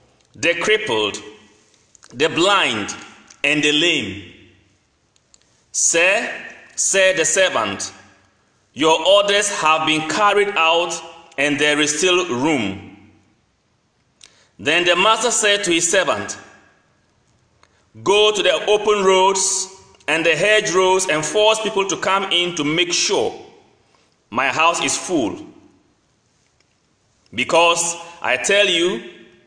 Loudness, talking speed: -16 LUFS, 110 wpm